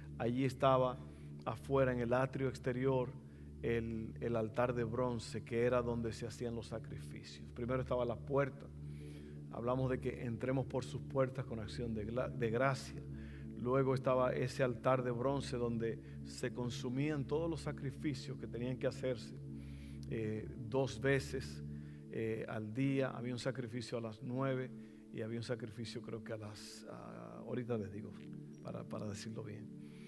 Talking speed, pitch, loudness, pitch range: 160 wpm, 120 Hz, -39 LUFS, 105-130 Hz